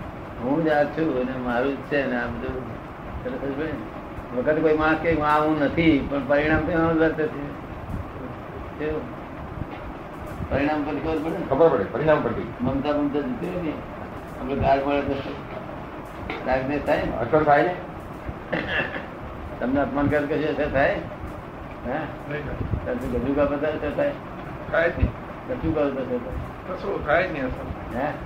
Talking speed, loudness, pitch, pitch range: 35 wpm, -24 LUFS, 145 Hz, 135-155 Hz